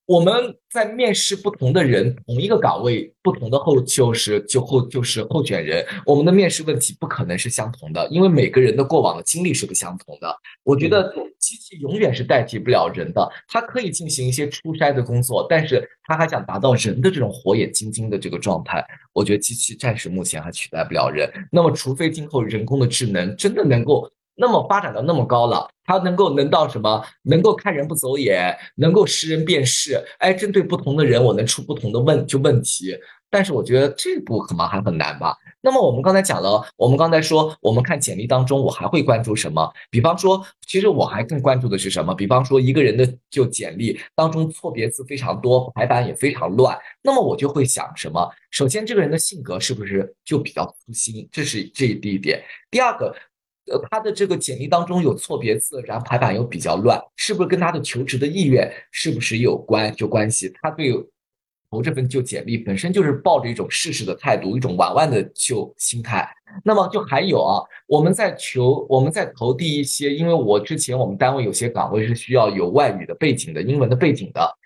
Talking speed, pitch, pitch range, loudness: 325 characters per minute, 140 Hz, 120-175 Hz, -19 LUFS